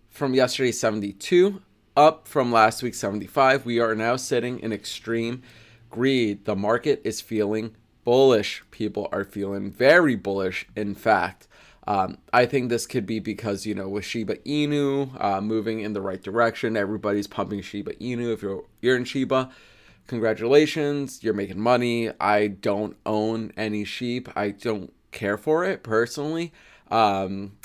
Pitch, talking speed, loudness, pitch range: 110 Hz, 150 wpm, -24 LUFS, 105-125 Hz